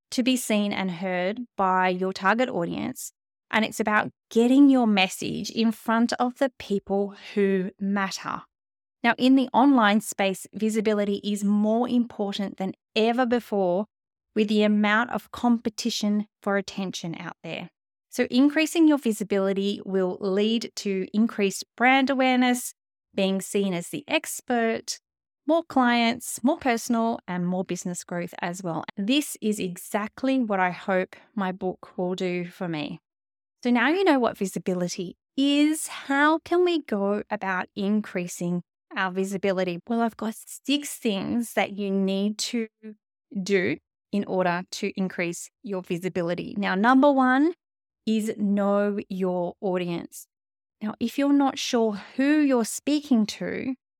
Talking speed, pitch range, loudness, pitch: 140 wpm, 190-245 Hz, -25 LUFS, 210 Hz